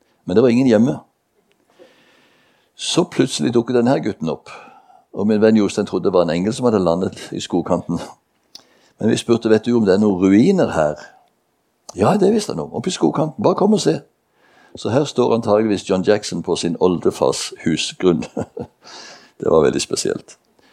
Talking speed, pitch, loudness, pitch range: 180 wpm, 110 Hz, -17 LUFS, 100-115 Hz